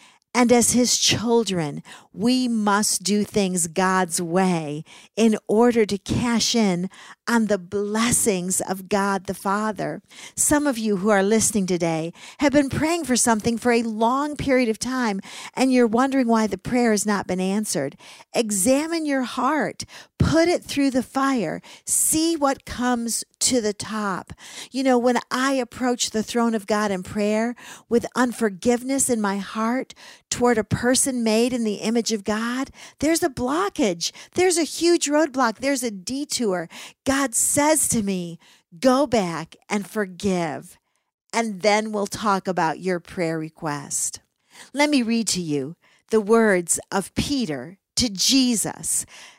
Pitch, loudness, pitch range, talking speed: 225 Hz, -22 LUFS, 200-255 Hz, 155 wpm